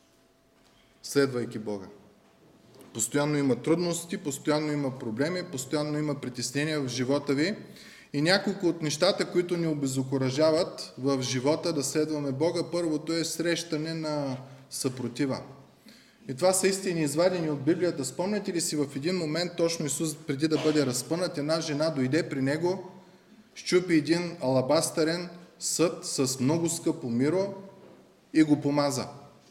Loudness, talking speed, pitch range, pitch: -28 LUFS, 135 wpm, 140-170 Hz, 155 Hz